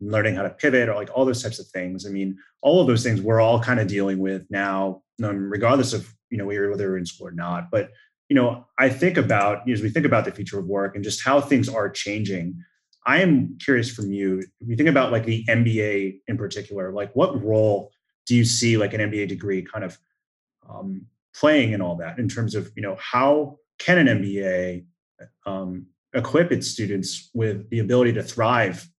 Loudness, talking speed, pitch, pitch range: -22 LUFS, 215 wpm, 105 Hz, 95-120 Hz